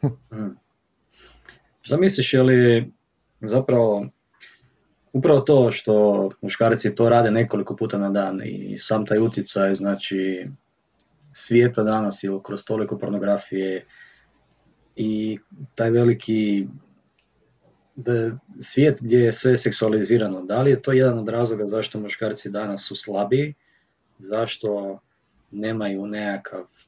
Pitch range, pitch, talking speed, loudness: 100-120 Hz, 110 Hz, 110 wpm, -21 LUFS